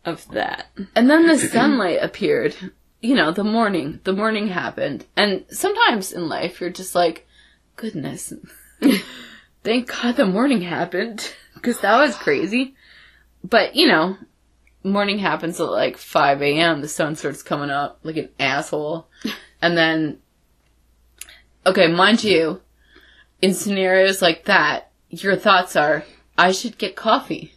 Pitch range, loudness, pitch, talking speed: 165-235 Hz, -19 LUFS, 190 Hz, 140 wpm